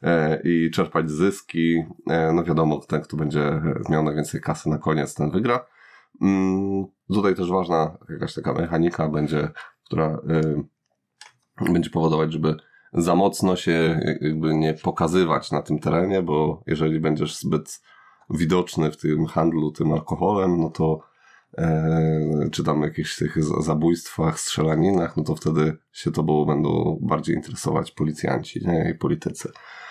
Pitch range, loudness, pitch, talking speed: 75-85 Hz, -23 LUFS, 80 Hz, 130 wpm